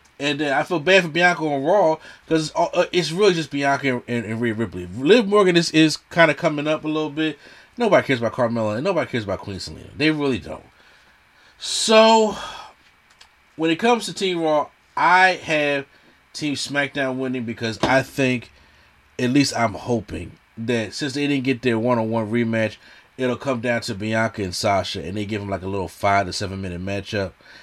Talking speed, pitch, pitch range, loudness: 200 wpm, 130 Hz, 110-155 Hz, -20 LUFS